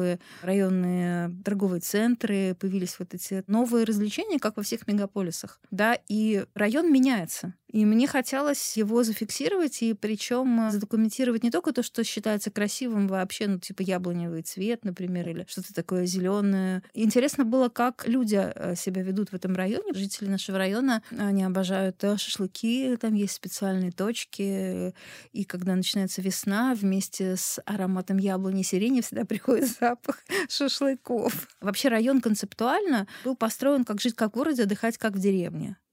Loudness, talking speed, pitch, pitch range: -27 LUFS, 145 wpm, 210 Hz, 190-240 Hz